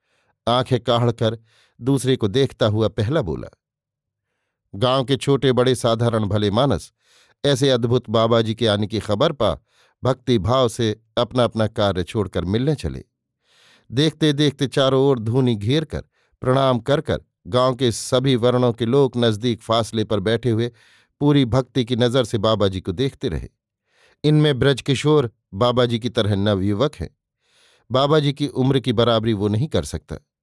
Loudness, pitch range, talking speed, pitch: -20 LUFS, 110-135 Hz, 160 wpm, 120 Hz